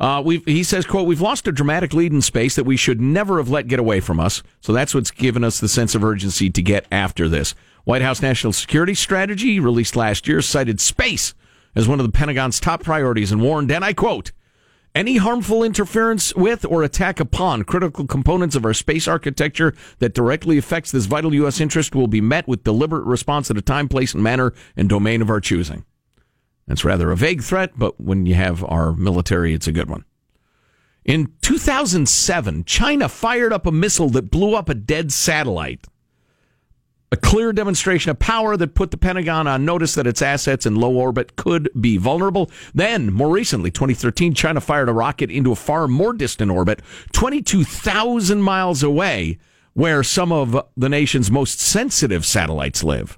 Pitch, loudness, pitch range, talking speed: 135 Hz, -18 LUFS, 110-170 Hz, 190 wpm